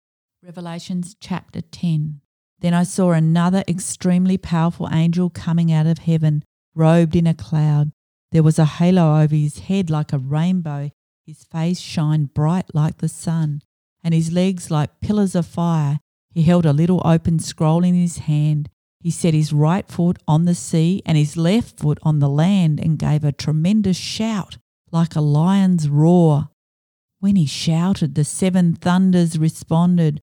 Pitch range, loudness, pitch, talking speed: 150-175 Hz, -18 LUFS, 165 Hz, 160 wpm